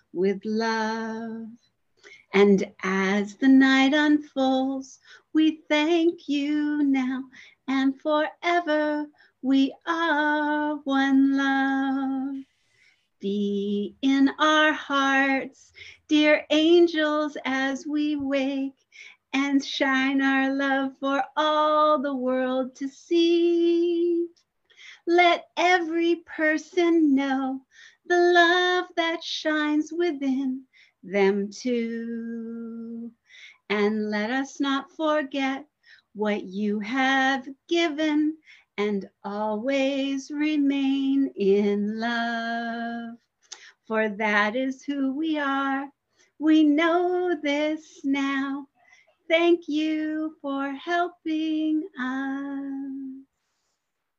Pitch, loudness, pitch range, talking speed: 275 Hz, -24 LUFS, 260-310 Hz, 85 wpm